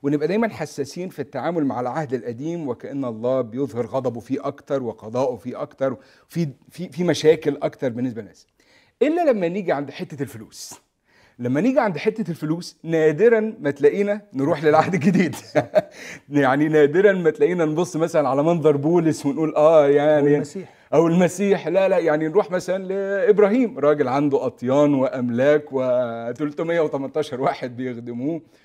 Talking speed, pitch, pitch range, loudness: 145 wpm, 150 Hz, 135-180 Hz, -21 LUFS